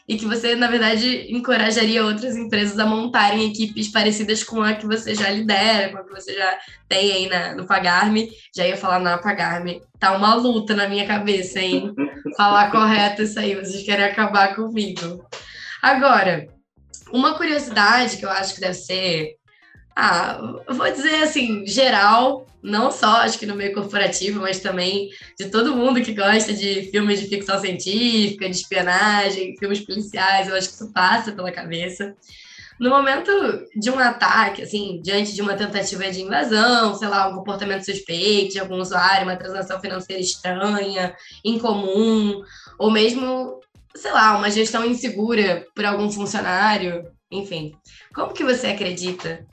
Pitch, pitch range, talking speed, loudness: 205 Hz, 190-220 Hz, 160 wpm, -19 LUFS